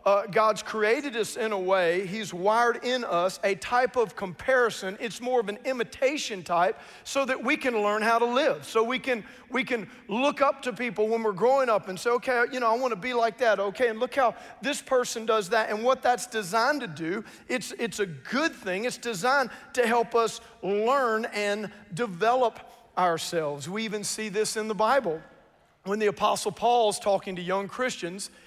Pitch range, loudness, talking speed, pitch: 205-250 Hz, -27 LUFS, 200 wpm, 225 Hz